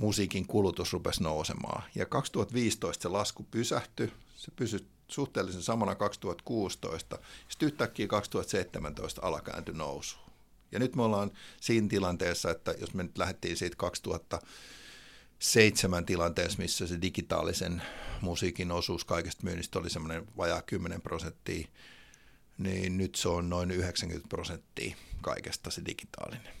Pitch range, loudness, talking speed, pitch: 90-110 Hz, -33 LUFS, 125 wpm, 95 Hz